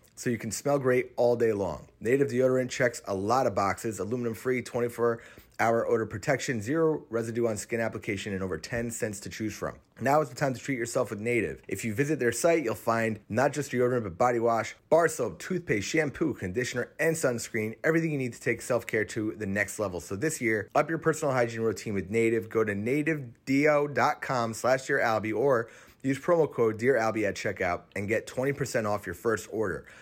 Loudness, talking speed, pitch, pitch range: -28 LUFS, 205 wpm, 120 Hz, 110-135 Hz